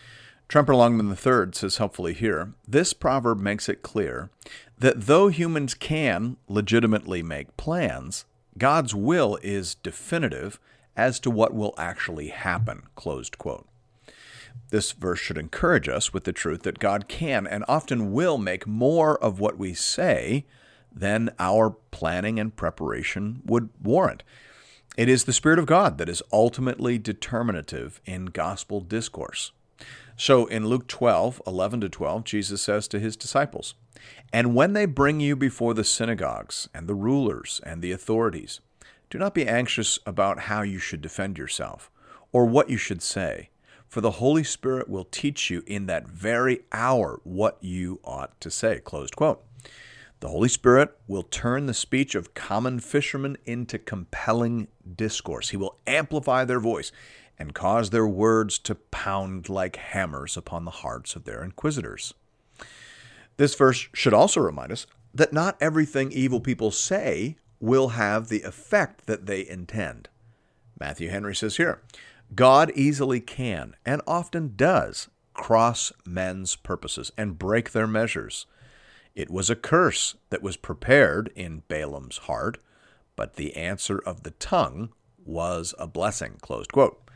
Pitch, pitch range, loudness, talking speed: 115 Hz, 100-130 Hz, -25 LUFS, 150 wpm